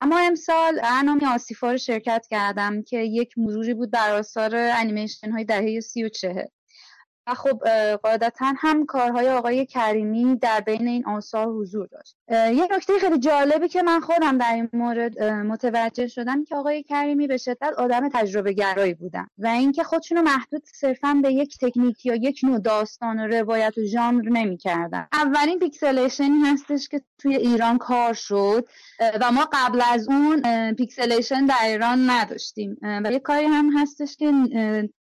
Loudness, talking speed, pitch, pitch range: -22 LUFS, 160 wpm, 245 Hz, 225-285 Hz